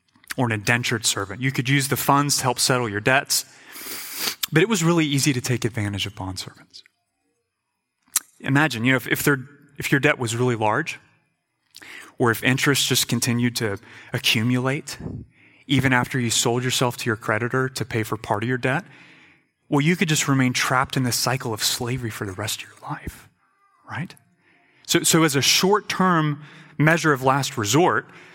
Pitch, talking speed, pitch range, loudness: 130 Hz, 180 wpm, 115-145 Hz, -21 LUFS